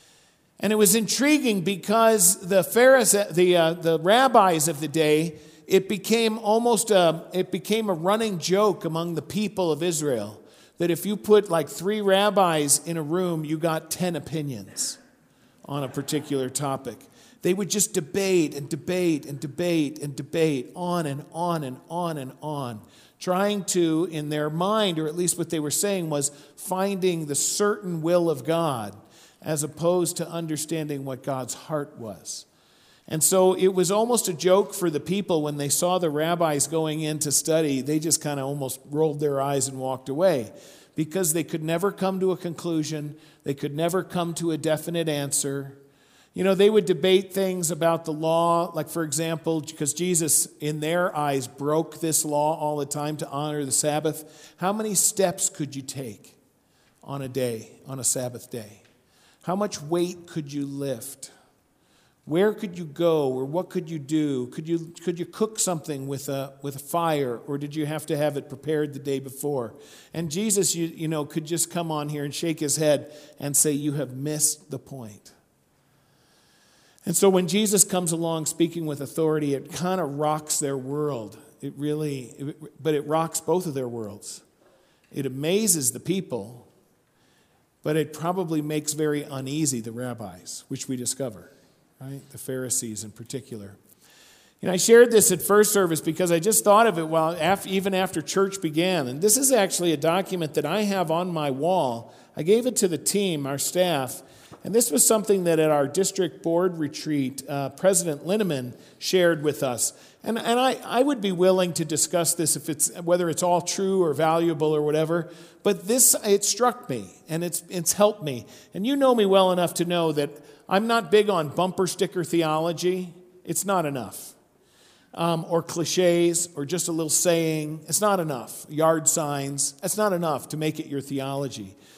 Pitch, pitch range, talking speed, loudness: 160 Hz, 145-185 Hz, 185 wpm, -24 LUFS